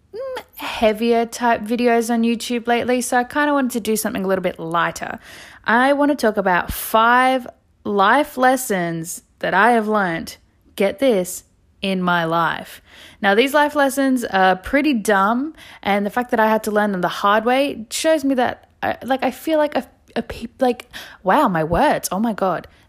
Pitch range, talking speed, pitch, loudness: 200-260 Hz, 190 wpm, 235 Hz, -18 LUFS